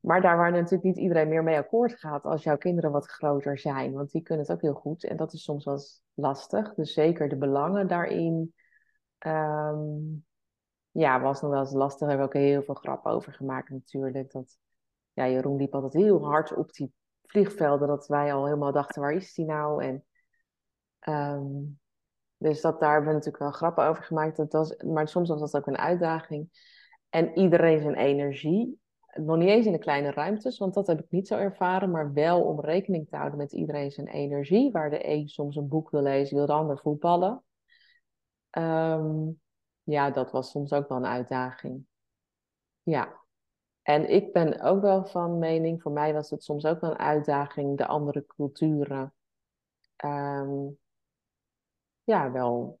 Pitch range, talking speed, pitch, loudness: 140-165 Hz, 185 wpm, 150 Hz, -27 LUFS